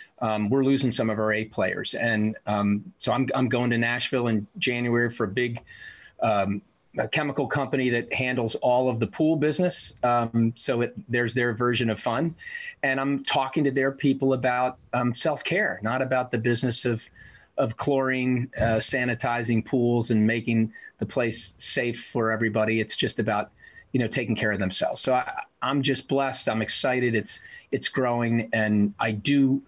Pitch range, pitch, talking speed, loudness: 110-135 Hz, 120 Hz, 180 wpm, -25 LUFS